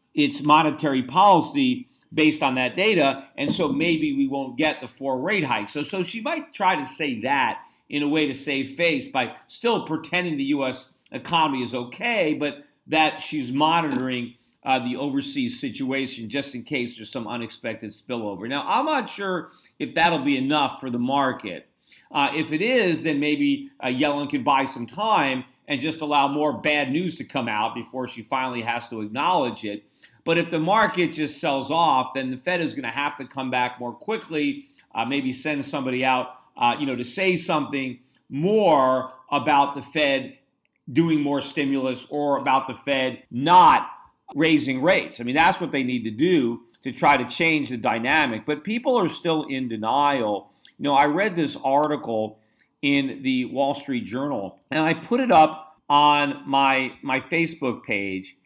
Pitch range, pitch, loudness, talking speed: 130-165 Hz, 145 Hz, -23 LUFS, 185 wpm